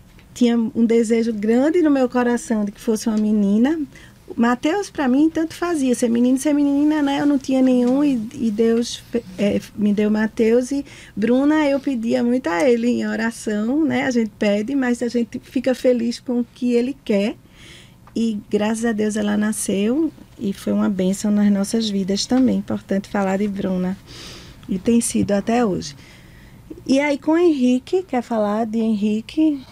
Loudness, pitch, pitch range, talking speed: -19 LUFS, 235 Hz, 215-265 Hz, 180 wpm